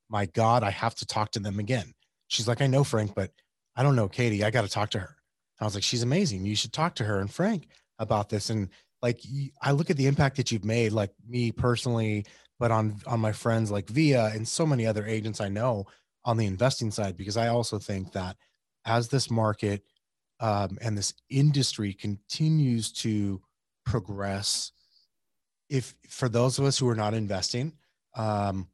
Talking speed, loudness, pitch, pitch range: 200 wpm, -28 LUFS, 115 Hz, 105-125 Hz